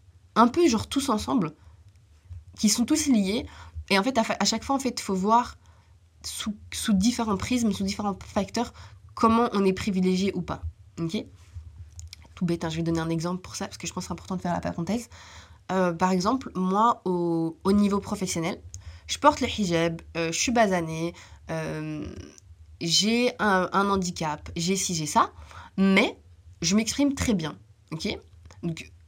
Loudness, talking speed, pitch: -26 LUFS, 185 wpm, 180 Hz